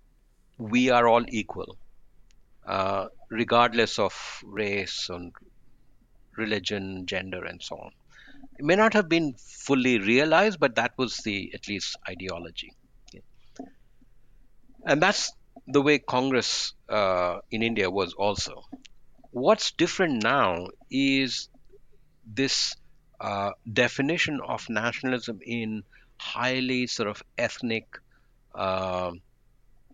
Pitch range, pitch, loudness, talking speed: 105-130 Hz, 115 Hz, -26 LUFS, 110 wpm